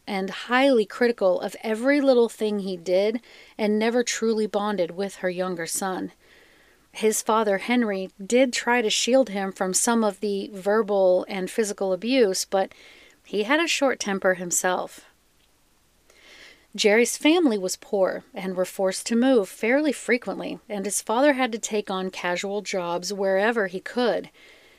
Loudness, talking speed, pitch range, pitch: -23 LUFS, 155 wpm, 190-235 Hz, 210 Hz